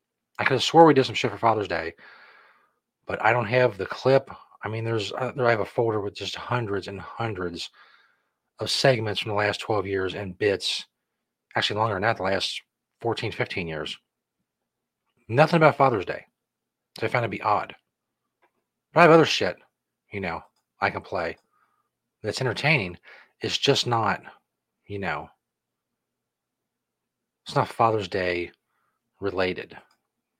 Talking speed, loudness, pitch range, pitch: 160 wpm, -24 LUFS, 100-125 Hz, 110 Hz